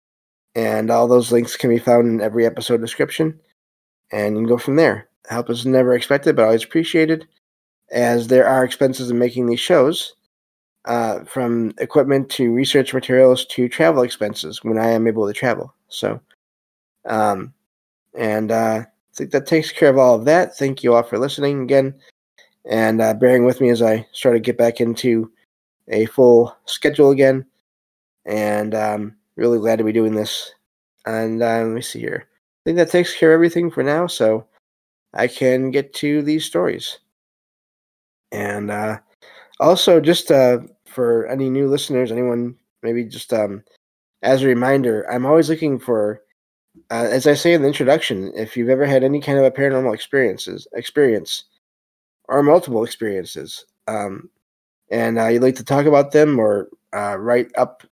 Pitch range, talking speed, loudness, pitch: 110-135 Hz, 170 wpm, -17 LUFS, 120 Hz